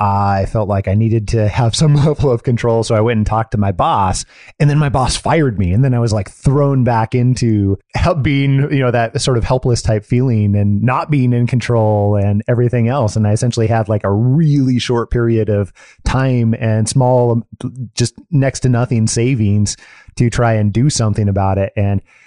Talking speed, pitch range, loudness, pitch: 205 wpm, 105-125 Hz, -14 LUFS, 115 Hz